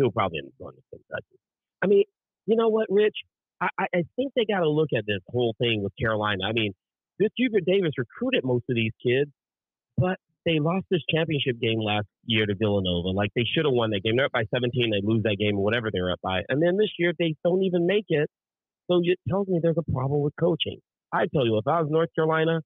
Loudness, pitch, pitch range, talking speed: -25 LUFS, 145 Hz, 110-175 Hz, 240 wpm